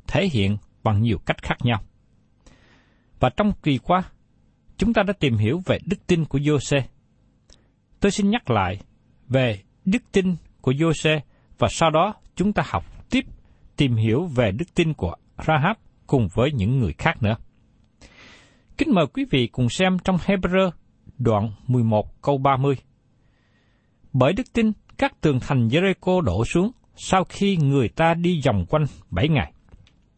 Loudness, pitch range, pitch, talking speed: -22 LUFS, 115-175 Hz, 140 Hz, 160 wpm